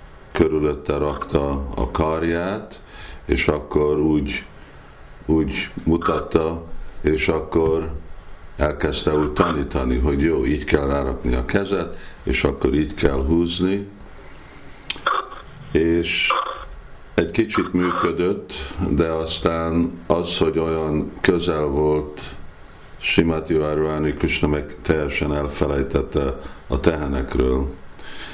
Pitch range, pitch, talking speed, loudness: 75-85 Hz, 80 Hz, 95 wpm, -21 LUFS